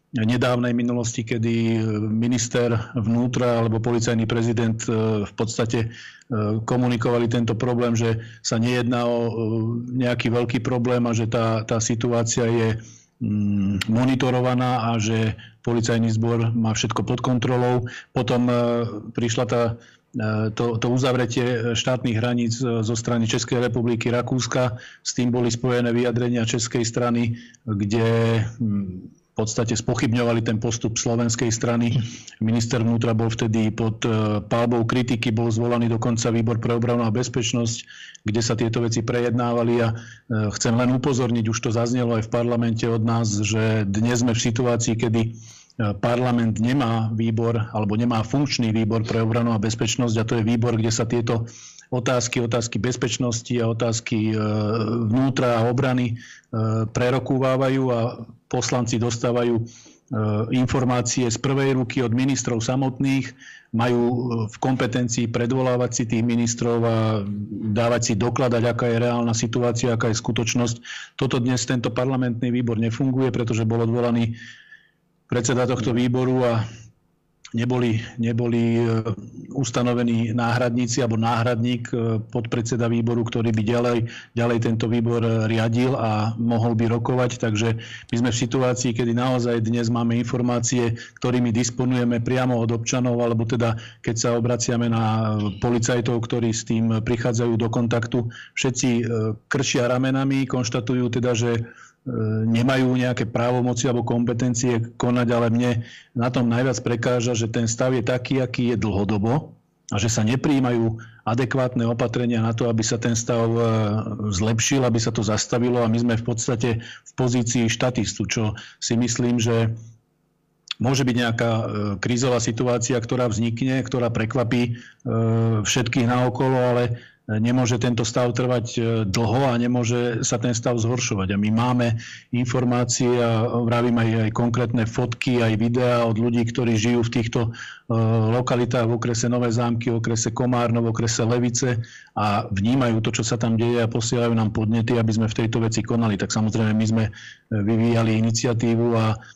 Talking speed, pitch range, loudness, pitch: 140 wpm, 115-125 Hz, -22 LUFS, 120 Hz